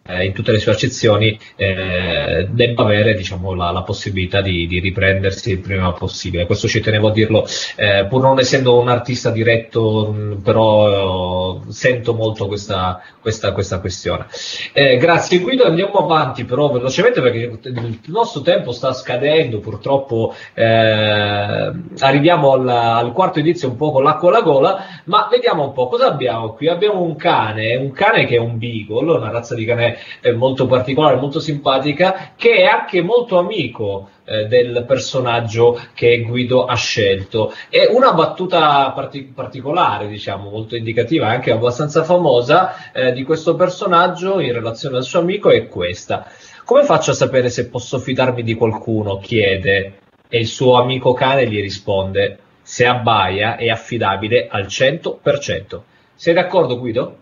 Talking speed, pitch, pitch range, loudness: 155 wpm, 120 Hz, 105-150 Hz, -16 LUFS